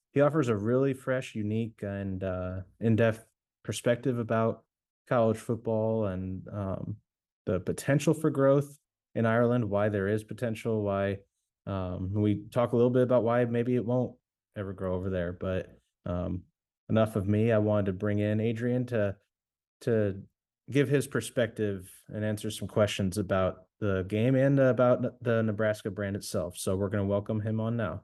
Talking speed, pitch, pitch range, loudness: 165 wpm, 110 Hz, 100-120 Hz, -29 LUFS